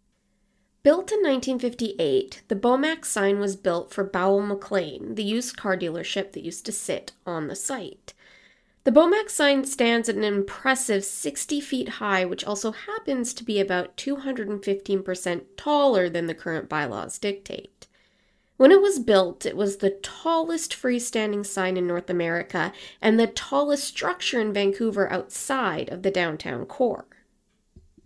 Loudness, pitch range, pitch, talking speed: -24 LUFS, 185-265 Hz, 205 Hz, 150 wpm